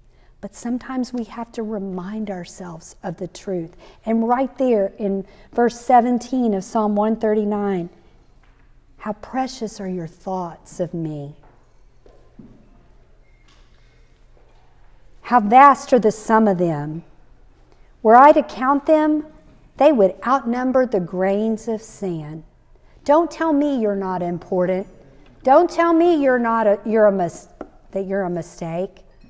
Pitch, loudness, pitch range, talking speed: 210 Hz, -19 LUFS, 180-245 Hz, 130 wpm